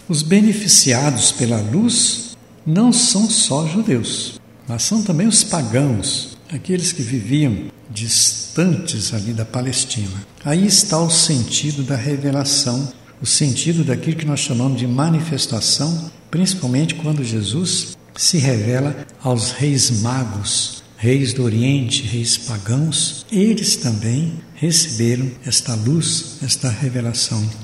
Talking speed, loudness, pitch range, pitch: 115 wpm, -17 LUFS, 120-160 Hz, 135 Hz